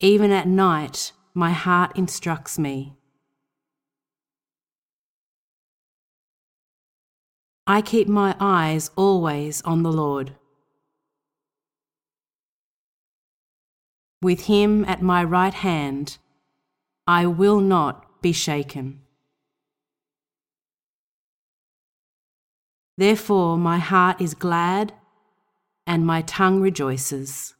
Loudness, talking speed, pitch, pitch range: -21 LUFS, 75 wpm, 175 Hz, 145-195 Hz